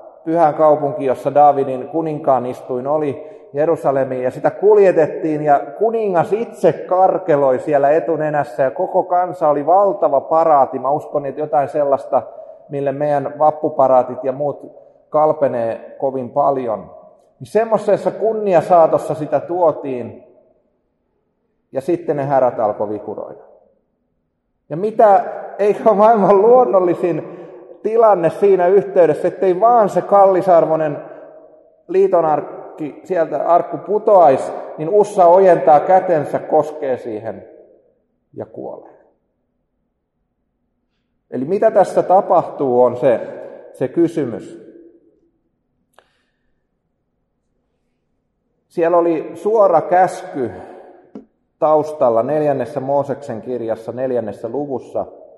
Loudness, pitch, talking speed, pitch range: -16 LUFS, 165 Hz, 100 wpm, 140-200 Hz